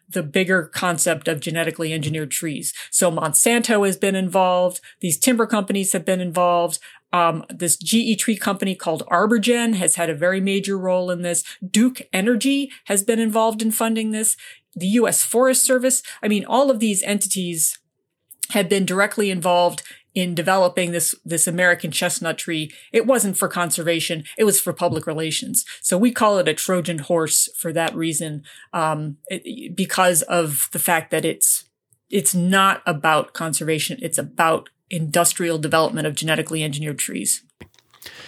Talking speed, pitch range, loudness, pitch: 160 wpm, 165-210 Hz, -19 LUFS, 180 Hz